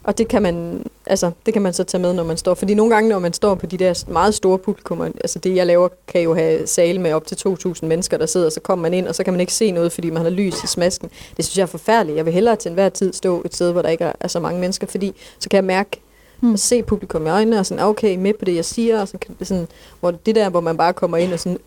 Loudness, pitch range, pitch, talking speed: -18 LUFS, 170-205 Hz, 185 Hz, 305 wpm